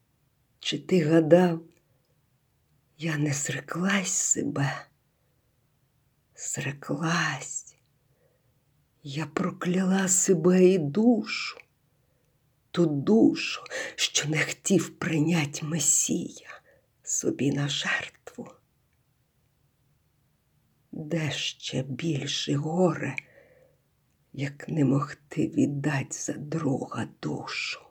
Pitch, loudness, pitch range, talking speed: 155 Hz, -26 LUFS, 140-180 Hz, 75 wpm